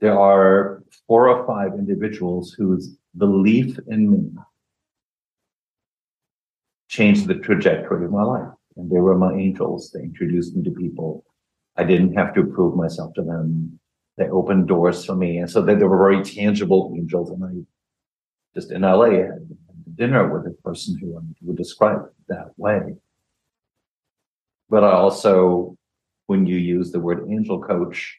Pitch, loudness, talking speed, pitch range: 95 Hz, -19 LUFS, 155 wpm, 90-105 Hz